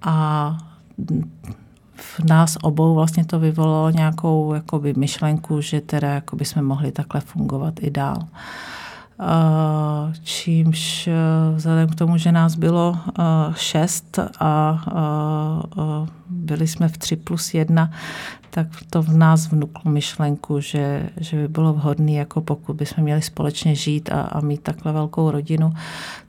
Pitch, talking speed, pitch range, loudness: 160 Hz, 130 wpm, 150-165 Hz, -20 LUFS